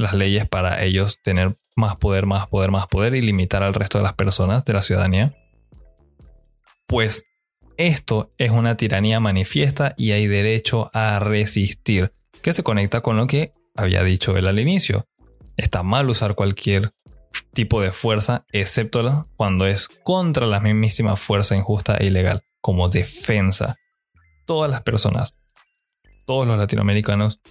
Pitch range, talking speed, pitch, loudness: 95-115 Hz, 150 wpm, 105 Hz, -20 LUFS